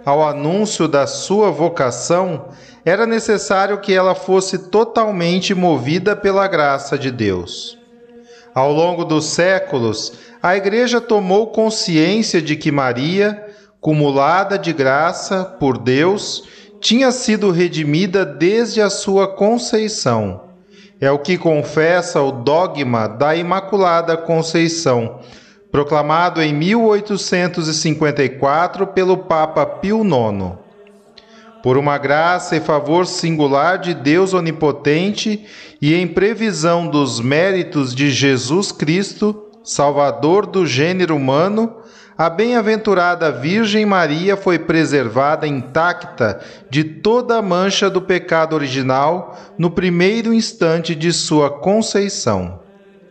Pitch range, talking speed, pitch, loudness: 150-205 Hz, 110 wpm, 175 Hz, -16 LUFS